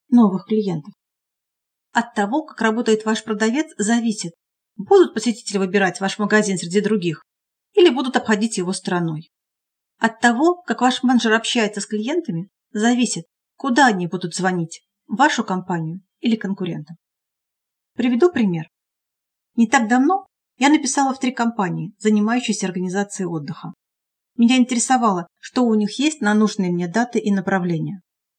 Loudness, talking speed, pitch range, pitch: -19 LUFS, 135 wpm, 190-245 Hz, 215 Hz